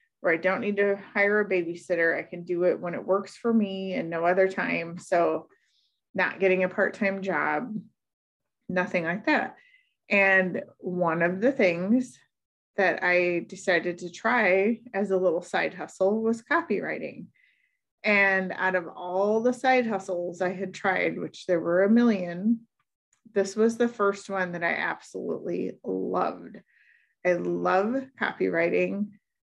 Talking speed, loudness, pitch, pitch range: 155 wpm, -26 LUFS, 190 Hz, 180-215 Hz